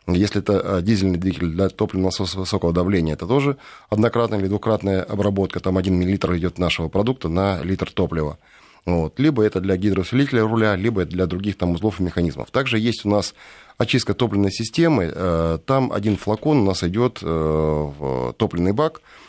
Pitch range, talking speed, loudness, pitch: 90-110 Hz, 160 wpm, -21 LUFS, 95 Hz